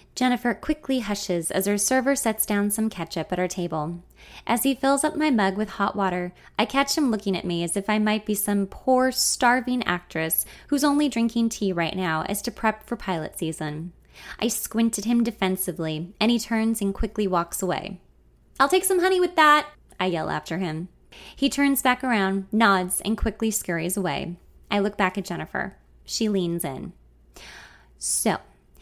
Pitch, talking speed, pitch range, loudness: 205 Hz, 185 wpm, 180-240 Hz, -24 LUFS